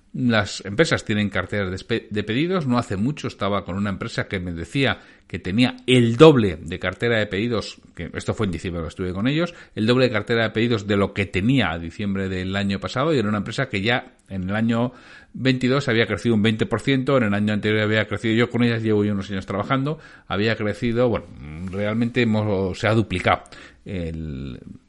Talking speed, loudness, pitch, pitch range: 205 wpm, -22 LUFS, 110 Hz, 100-120 Hz